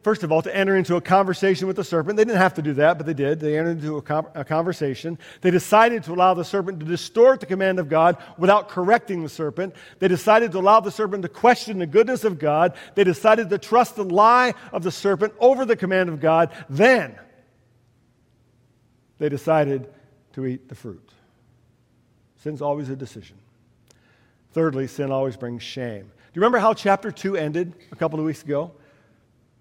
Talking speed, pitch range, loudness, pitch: 195 wpm, 135-195 Hz, -20 LUFS, 165 Hz